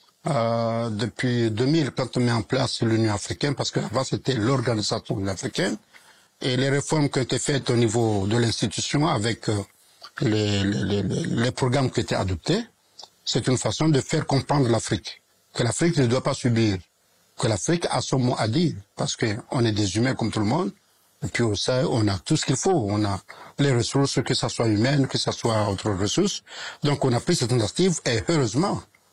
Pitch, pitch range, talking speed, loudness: 120 Hz, 110-135 Hz, 200 wpm, -24 LUFS